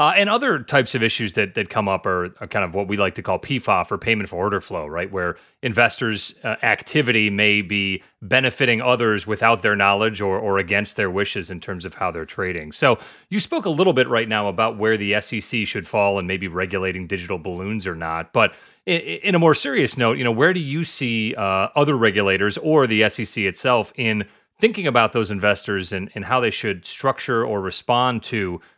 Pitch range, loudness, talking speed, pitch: 100-125 Hz, -20 LUFS, 215 wpm, 110 Hz